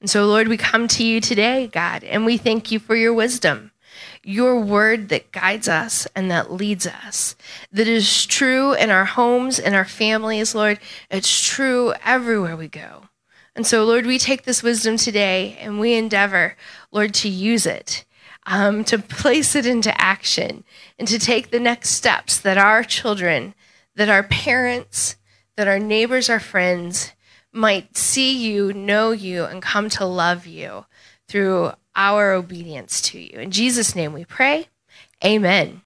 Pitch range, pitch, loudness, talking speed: 195-230 Hz, 215 Hz, -18 LUFS, 165 wpm